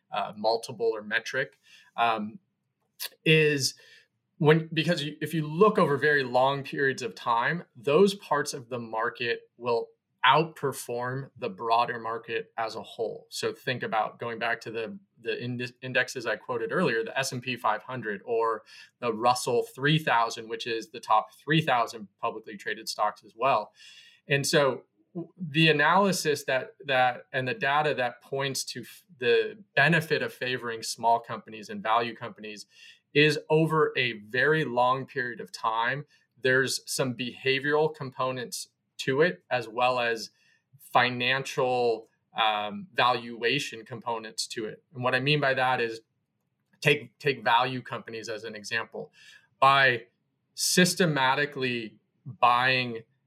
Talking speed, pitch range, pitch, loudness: 145 wpm, 120-155 Hz, 130 Hz, -27 LUFS